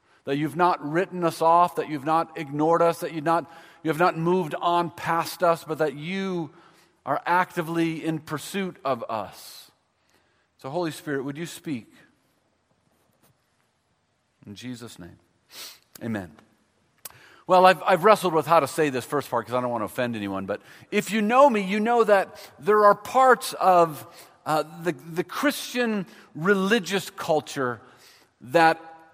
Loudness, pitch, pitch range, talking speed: -24 LUFS, 165 Hz, 150-185 Hz, 155 wpm